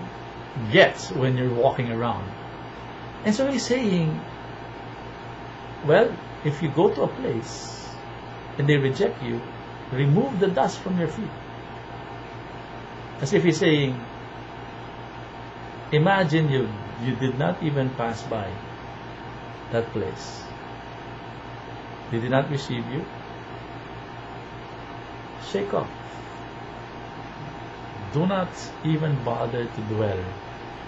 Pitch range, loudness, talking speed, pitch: 115-140 Hz, -25 LUFS, 105 wpm, 125 Hz